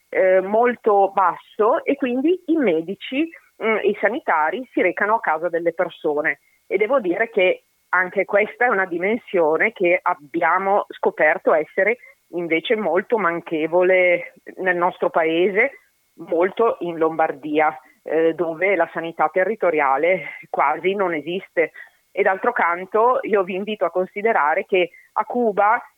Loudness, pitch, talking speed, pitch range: -20 LUFS, 185 Hz, 130 wpm, 170-220 Hz